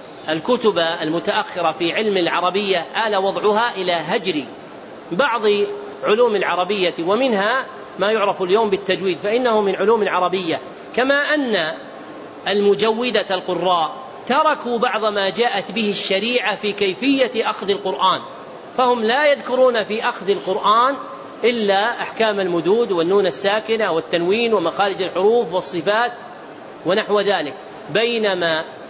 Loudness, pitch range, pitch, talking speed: -19 LUFS, 185-230 Hz, 205 Hz, 110 wpm